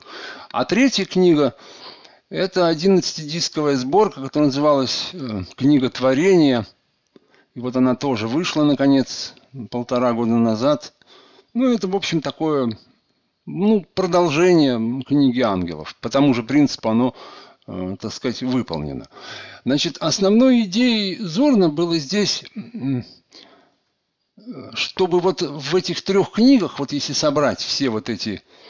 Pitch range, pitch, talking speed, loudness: 125-185 Hz, 150 Hz, 115 wpm, -19 LUFS